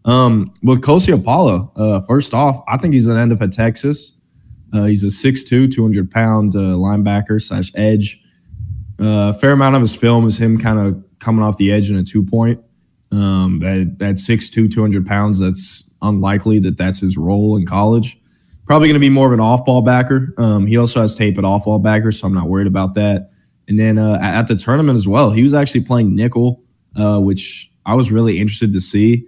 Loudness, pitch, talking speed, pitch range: -14 LUFS, 110 Hz, 215 wpm, 100-120 Hz